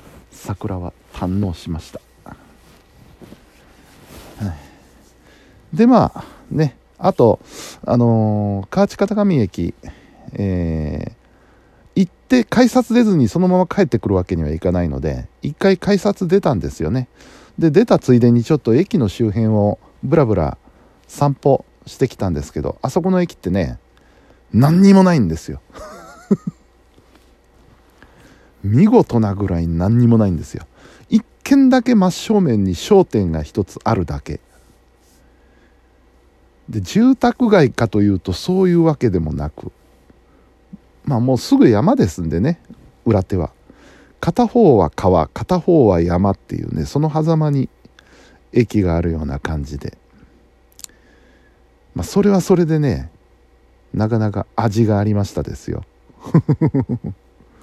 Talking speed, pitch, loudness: 235 characters per minute, 110 Hz, -17 LUFS